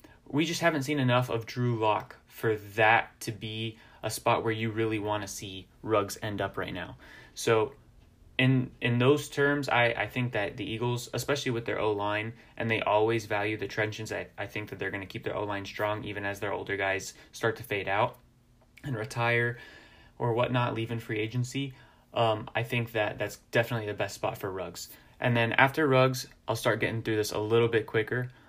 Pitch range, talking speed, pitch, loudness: 110-125 Hz, 205 wpm, 115 Hz, -29 LUFS